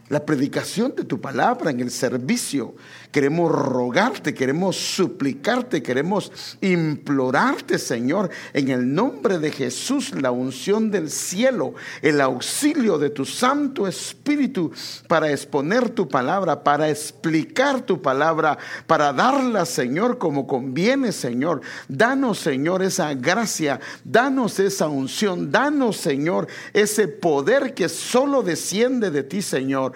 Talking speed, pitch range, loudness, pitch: 120 wpm, 140-235 Hz, -21 LUFS, 170 Hz